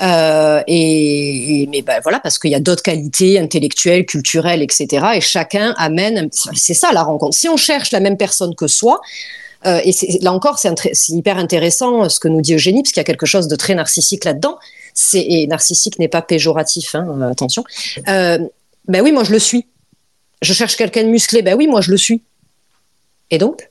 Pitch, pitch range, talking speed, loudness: 180 Hz, 160-215 Hz, 215 wpm, -13 LUFS